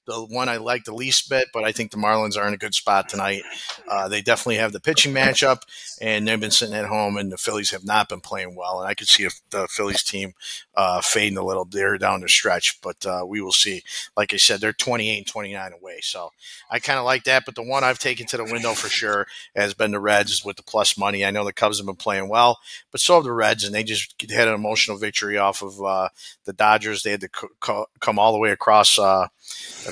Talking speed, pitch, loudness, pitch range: 255 wpm, 105 Hz, -20 LUFS, 100-120 Hz